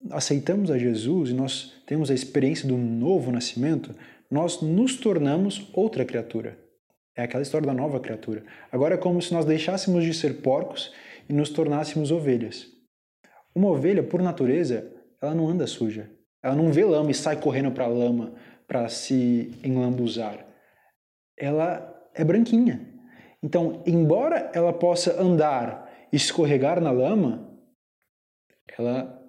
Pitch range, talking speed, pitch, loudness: 125-170 Hz, 140 wpm, 150 Hz, -24 LUFS